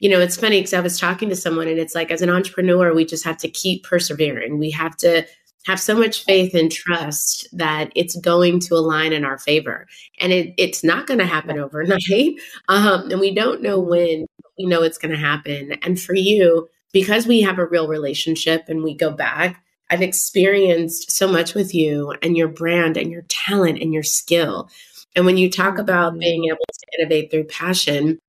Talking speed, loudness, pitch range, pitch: 210 wpm, -18 LUFS, 160-185 Hz, 170 Hz